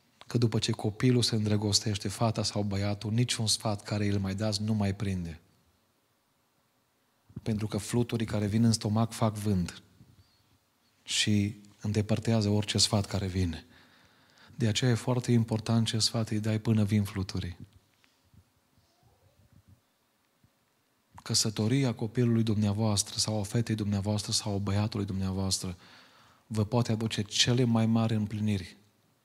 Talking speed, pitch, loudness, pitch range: 130 wpm, 110 Hz, -29 LUFS, 105-115 Hz